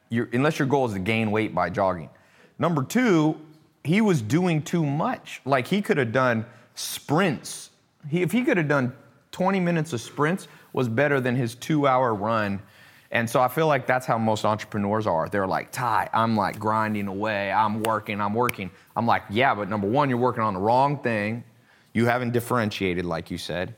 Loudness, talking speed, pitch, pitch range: -24 LUFS, 200 wpm, 120 Hz, 110-150 Hz